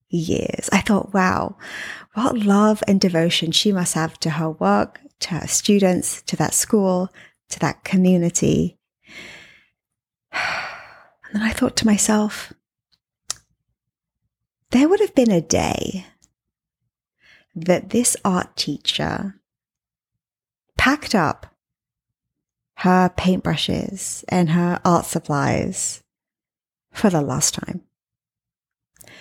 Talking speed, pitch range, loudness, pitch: 105 wpm, 175-215 Hz, -20 LUFS, 190 Hz